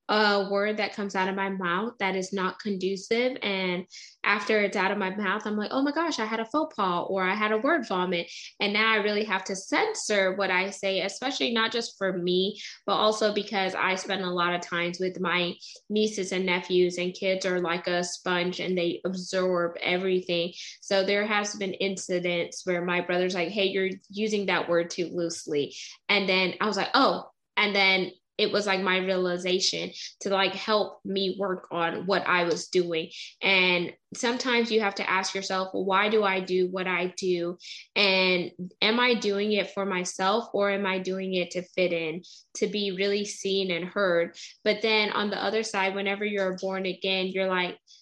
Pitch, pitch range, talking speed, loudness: 190 Hz, 180-205 Hz, 200 wpm, -26 LUFS